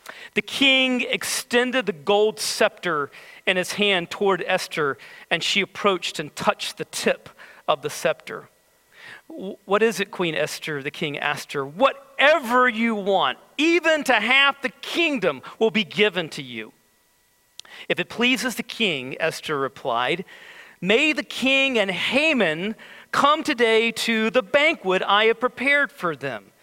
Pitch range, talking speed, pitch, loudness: 190-270 Hz, 145 wpm, 220 Hz, -21 LUFS